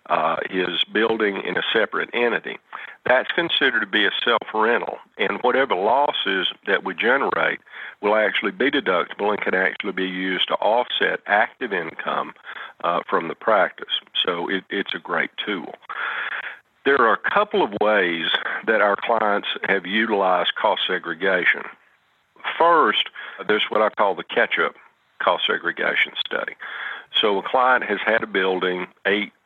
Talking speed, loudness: 150 wpm, -21 LUFS